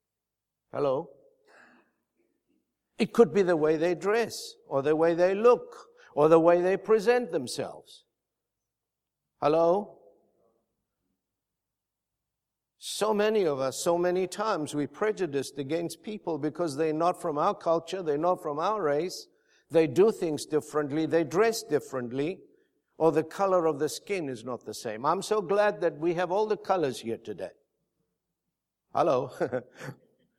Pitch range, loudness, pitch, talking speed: 135-200 Hz, -27 LUFS, 165 Hz, 140 wpm